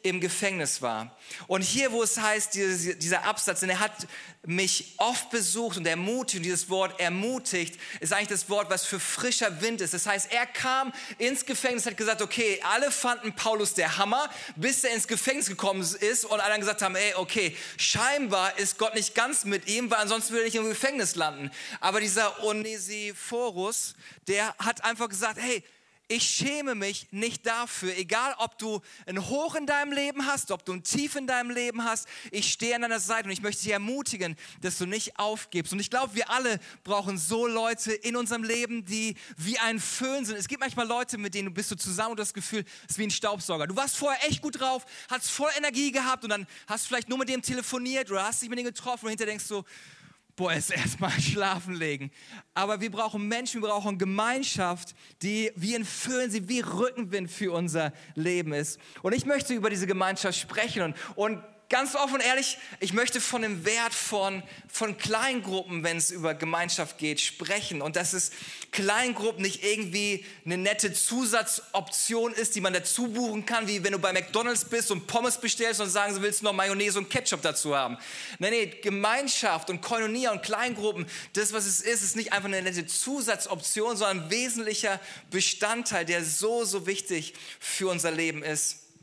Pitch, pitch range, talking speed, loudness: 210 Hz, 190-235 Hz, 200 wpm, -28 LUFS